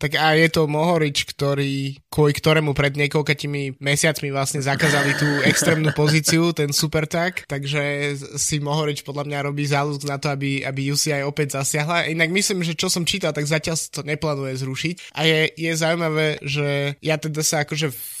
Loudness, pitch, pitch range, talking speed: -21 LUFS, 150 Hz, 140-160 Hz, 180 wpm